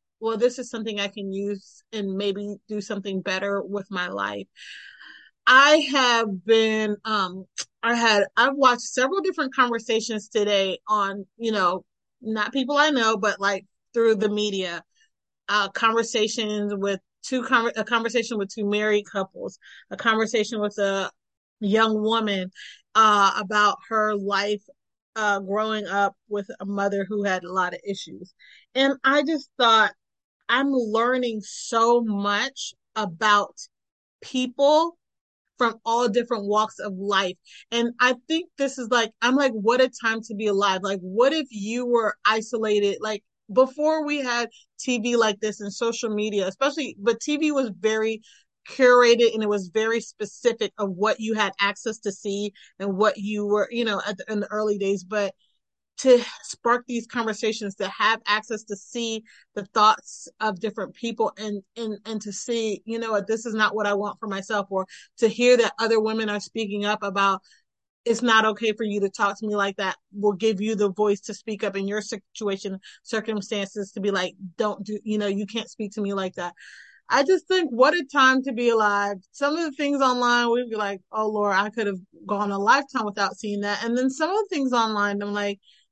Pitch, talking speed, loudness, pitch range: 215 Hz, 185 wpm, -23 LUFS, 205-235 Hz